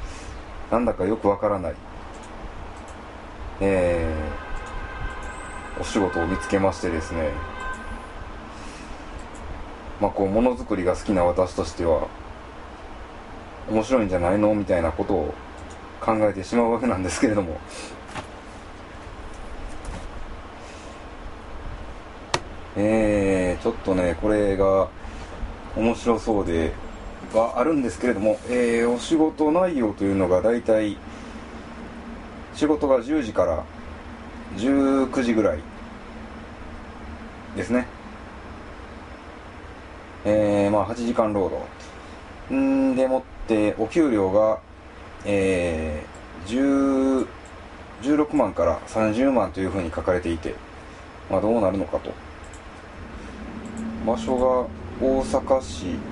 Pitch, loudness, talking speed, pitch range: 95 Hz, -23 LUFS, 190 characters per minute, 80-110 Hz